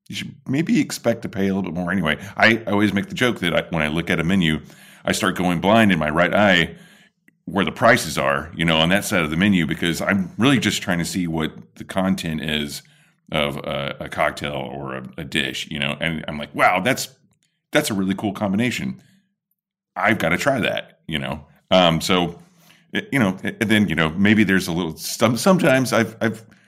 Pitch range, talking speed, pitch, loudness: 80-110 Hz, 225 wpm, 90 Hz, -20 LUFS